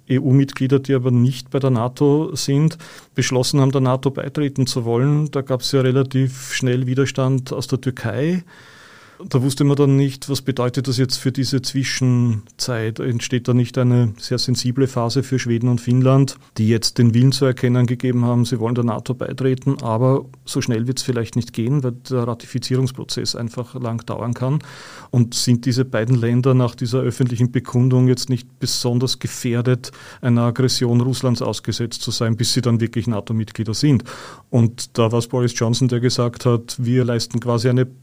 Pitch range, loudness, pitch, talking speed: 120-130 Hz, -19 LUFS, 125 Hz, 180 wpm